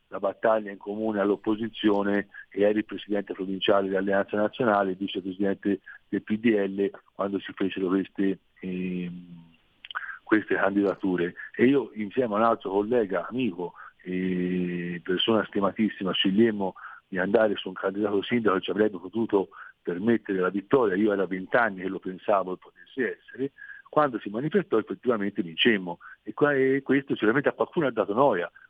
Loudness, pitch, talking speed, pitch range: -26 LUFS, 100 Hz, 145 wpm, 95-110 Hz